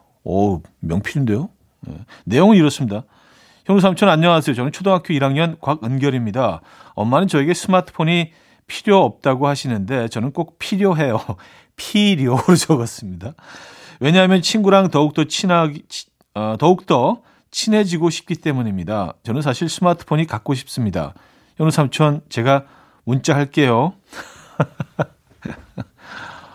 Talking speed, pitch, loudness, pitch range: 290 characters per minute, 150 Hz, -17 LUFS, 125-175 Hz